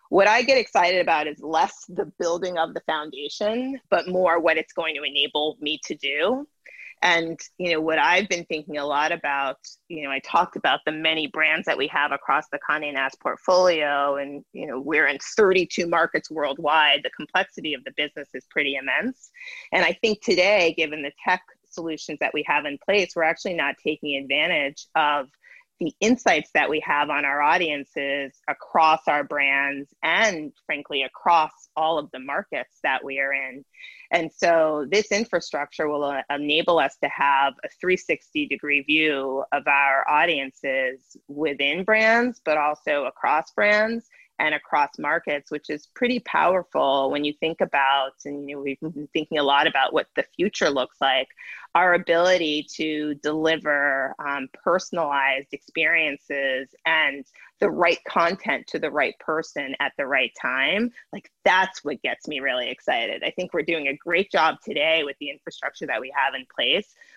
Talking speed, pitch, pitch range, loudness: 175 wpm, 155 Hz, 140-180 Hz, -23 LUFS